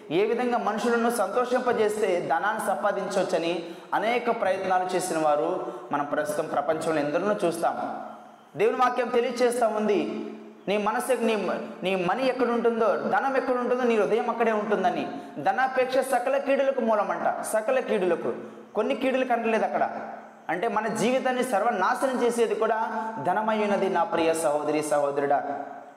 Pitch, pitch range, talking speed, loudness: 220 Hz, 180-250 Hz, 120 wpm, -26 LUFS